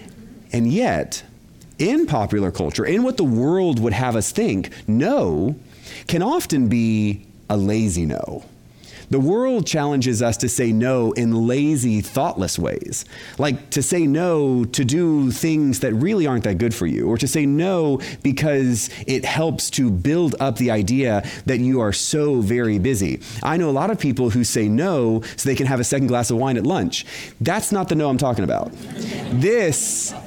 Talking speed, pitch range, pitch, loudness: 180 wpm, 115-145 Hz, 130 Hz, -20 LUFS